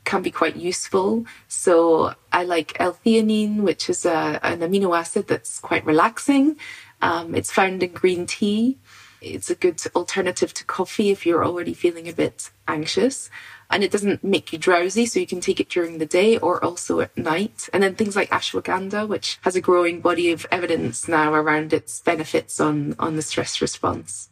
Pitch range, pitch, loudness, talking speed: 165-200 Hz, 180 Hz, -21 LUFS, 185 wpm